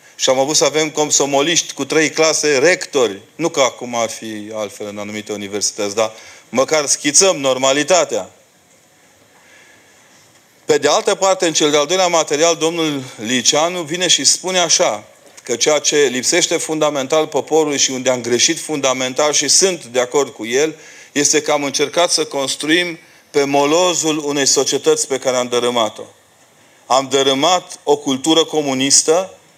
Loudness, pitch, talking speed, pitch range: -15 LUFS, 150 Hz, 150 wpm, 130-160 Hz